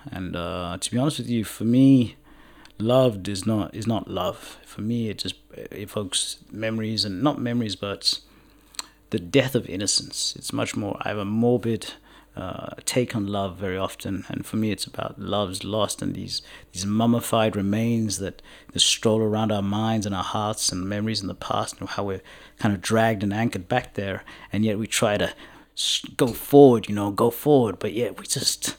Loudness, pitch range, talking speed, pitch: -24 LUFS, 100-115 Hz, 200 wpm, 110 Hz